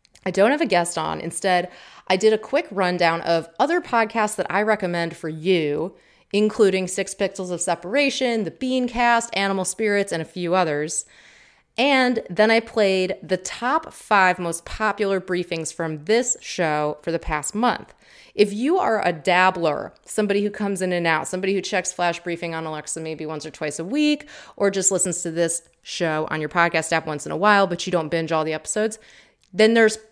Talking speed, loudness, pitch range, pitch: 195 wpm, -22 LUFS, 170-215 Hz, 185 Hz